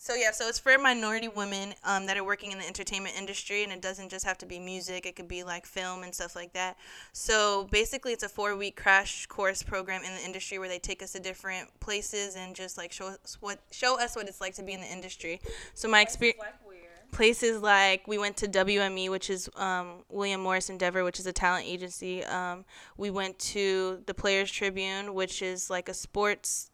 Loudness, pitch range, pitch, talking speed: -30 LUFS, 185-205 Hz, 195 Hz, 220 wpm